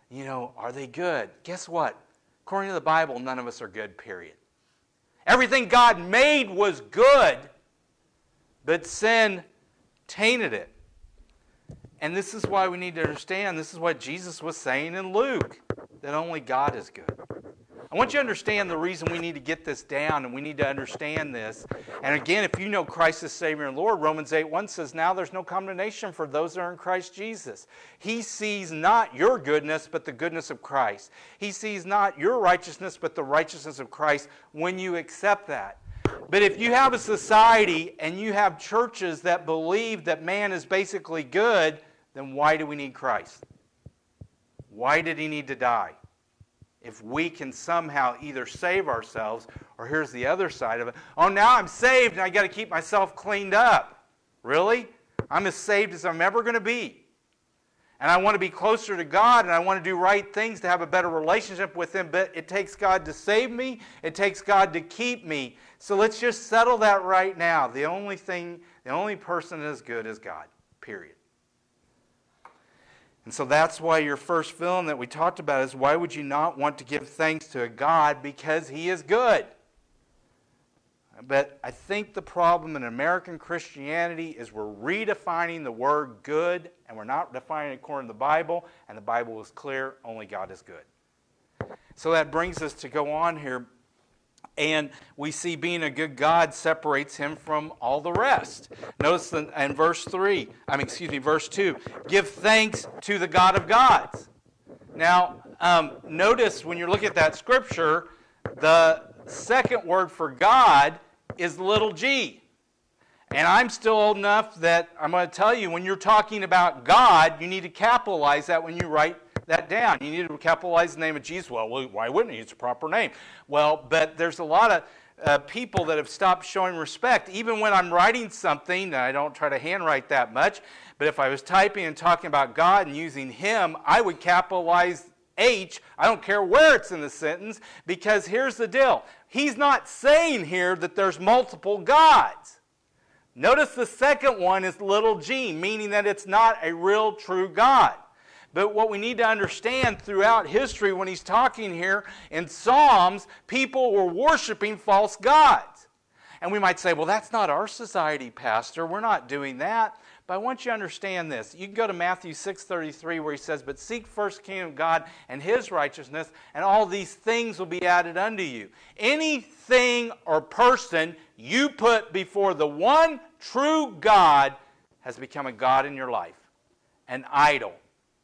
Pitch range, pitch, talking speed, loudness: 155-210 Hz, 180 Hz, 185 wpm, -24 LUFS